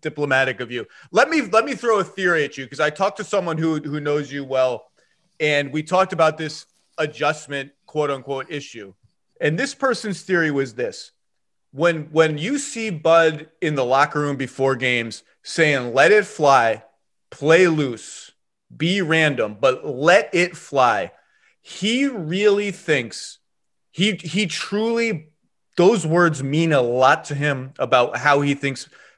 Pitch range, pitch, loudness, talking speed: 140-180 Hz, 155 Hz, -20 LUFS, 160 wpm